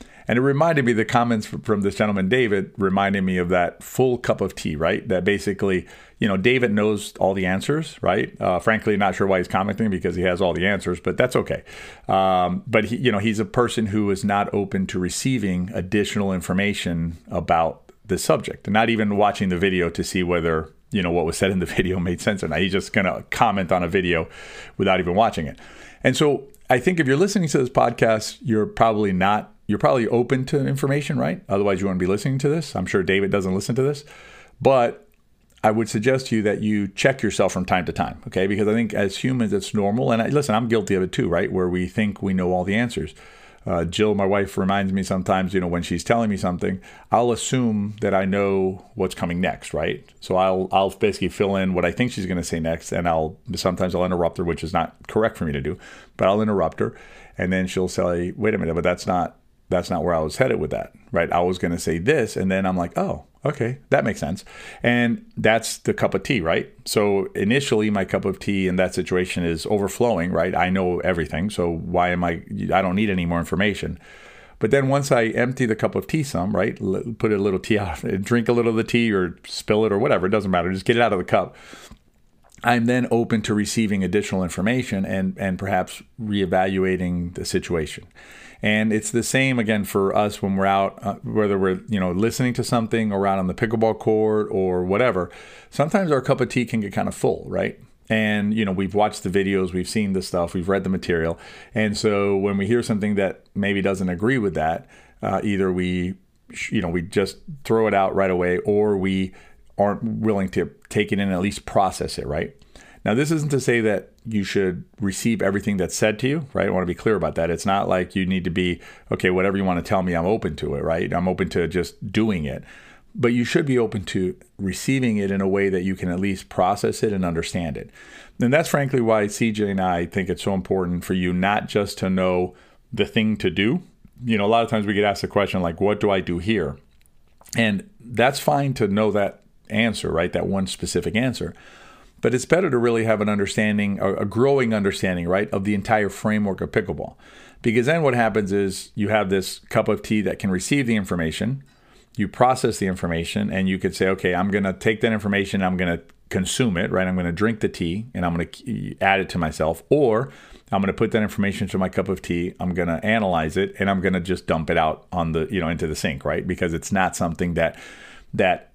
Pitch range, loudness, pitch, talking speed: 95-110 Hz, -22 LUFS, 100 Hz, 235 wpm